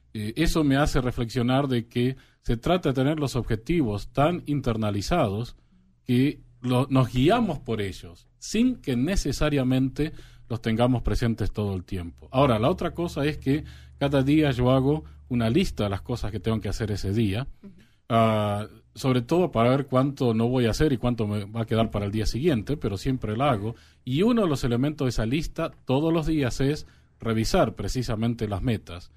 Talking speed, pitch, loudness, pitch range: 185 wpm, 125 Hz, -25 LUFS, 110-140 Hz